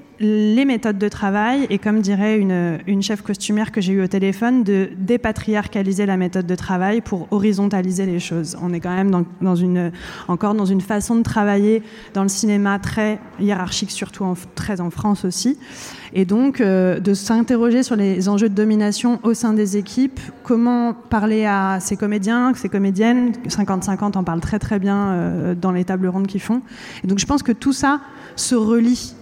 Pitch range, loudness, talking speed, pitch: 190-225 Hz, -19 LUFS, 190 wpm, 205 Hz